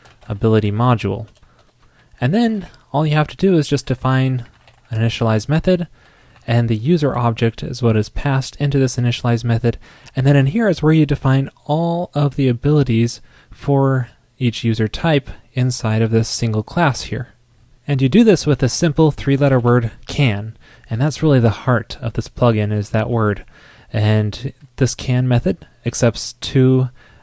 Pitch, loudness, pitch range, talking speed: 125 Hz, -17 LUFS, 115-140 Hz, 170 wpm